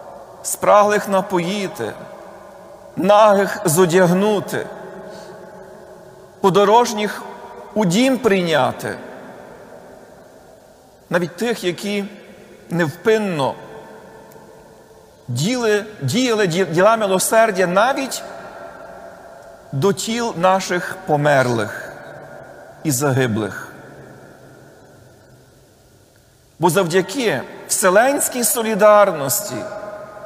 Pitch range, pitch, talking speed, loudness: 175-210 Hz, 200 Hz, 50 wpm, -17 LUFS